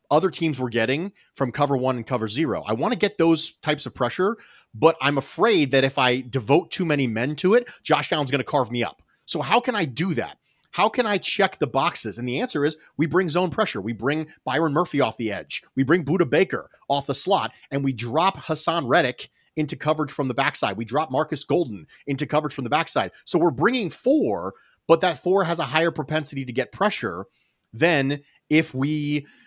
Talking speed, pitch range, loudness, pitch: 220 wpm, 135-165 Hz, -23 LUFS, 150 Hz